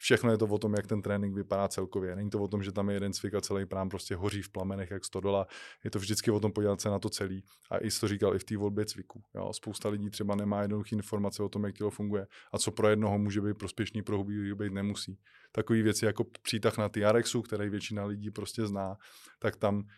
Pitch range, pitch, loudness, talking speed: 100-105 Hz, 105 Hz, -33 LUFS, 250 wpm